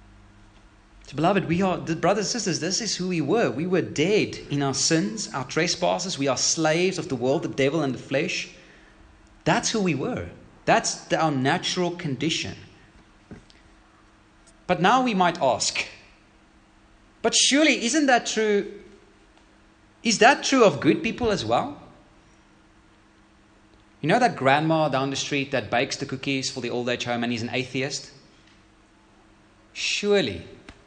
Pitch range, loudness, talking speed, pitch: 110-180 Hz, -23 LUFS, 155 wpm, 140 Hz